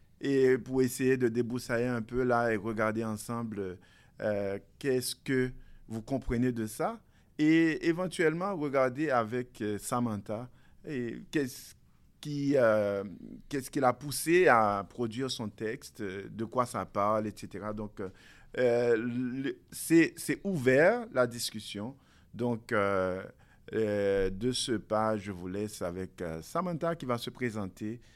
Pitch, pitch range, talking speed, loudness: 120 Hz, 105-130 Hz, 130 wpm, -31 LUFS